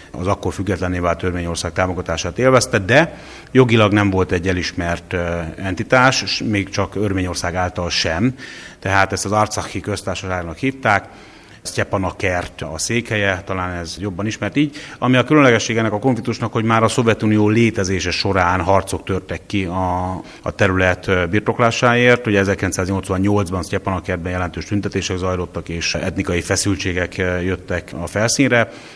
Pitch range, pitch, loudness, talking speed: 90-110 Hz, 95 Hz, -18 LUFS, 135 wpm